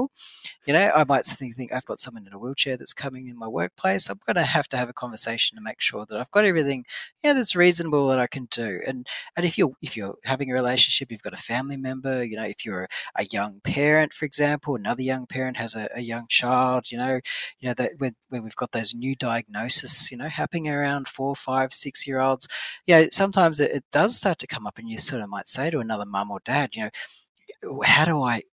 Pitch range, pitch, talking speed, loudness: 120-145 Hz, 130 Hz, 250 wpm, -23 LUFS